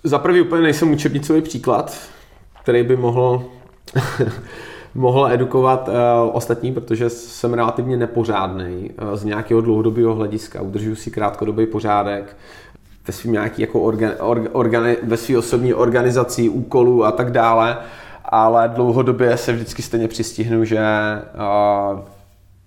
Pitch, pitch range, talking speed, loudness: 115 Hz, 105-125 Hz, 120 wpm, -18 LUFS